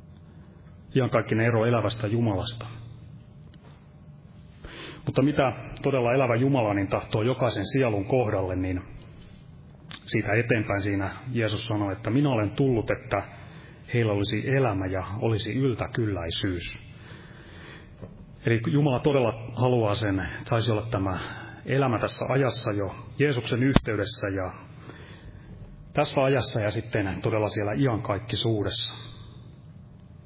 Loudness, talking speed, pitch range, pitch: -26 LUFS, 105 wpm, 105-130 Hz, 115 Hz